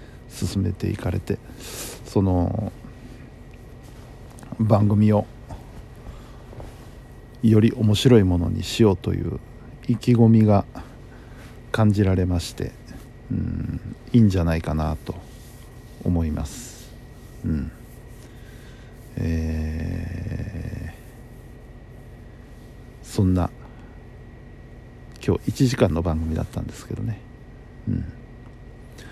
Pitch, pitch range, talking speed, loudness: 115 Hz, 100-120 Hz, 165 characters per minute, -23 LUFS